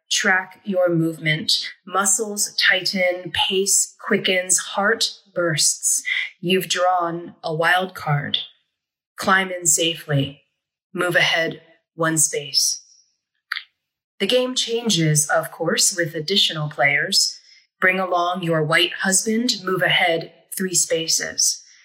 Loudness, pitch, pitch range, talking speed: -19 LUFS, 180 Hz, 165-195 Hz, 105 wpm